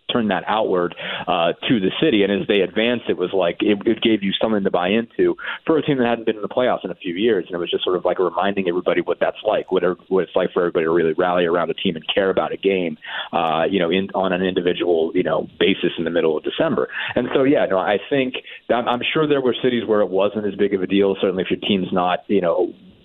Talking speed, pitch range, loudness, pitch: 280 wpm, 95-120 Hz, -20 LUFS, 105 Hz